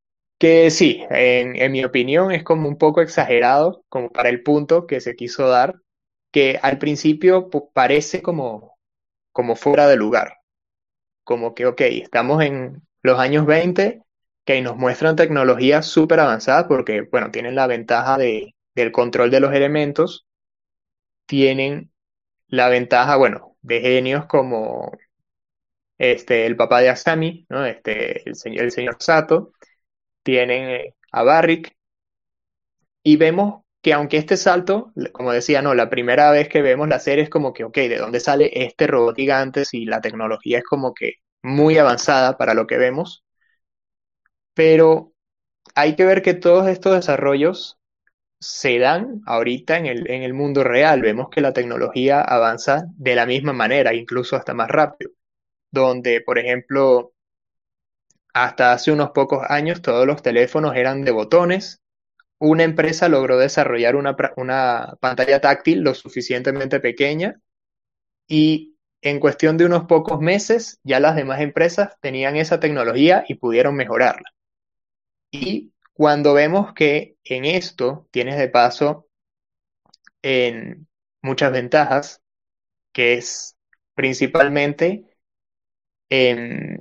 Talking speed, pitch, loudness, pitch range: 140 wpm, 145 Hz, -17 LUFS, 125-160 Hz